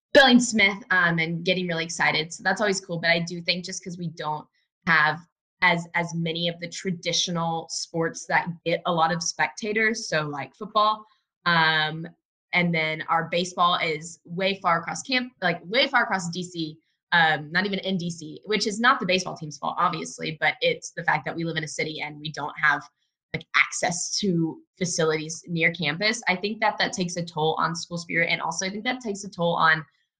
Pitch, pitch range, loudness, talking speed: 175 Hz, 165-195 Hz, -24 LUFS, 205 wpm